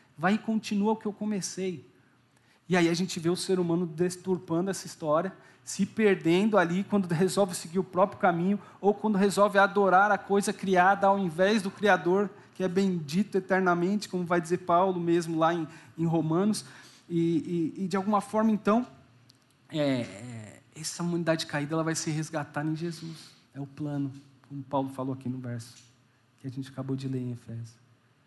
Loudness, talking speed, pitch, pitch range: -28 LUFS, 180 wpm, 170 Hz, 140-195 Hz